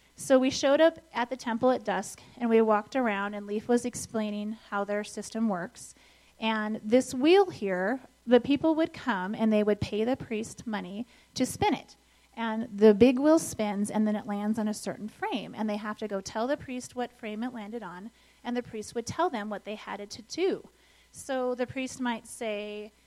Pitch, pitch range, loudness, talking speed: 225 Hz, 210-250 Hz, -29 LUFS, 215 wpm